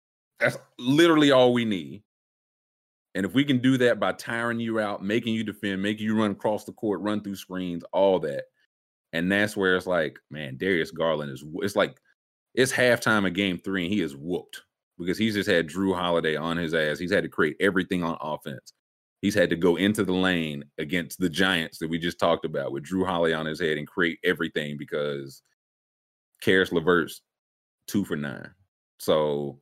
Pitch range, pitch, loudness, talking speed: 85-110 Hz, 95 Hz, -25 LUFS, 195 wpm